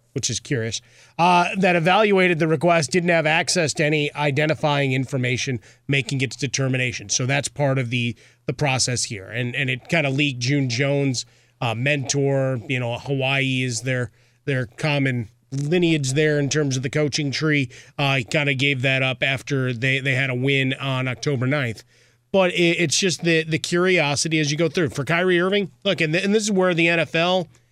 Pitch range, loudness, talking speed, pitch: 130-160 Hz, -21 LUFS, 195 wpm, 140 Hz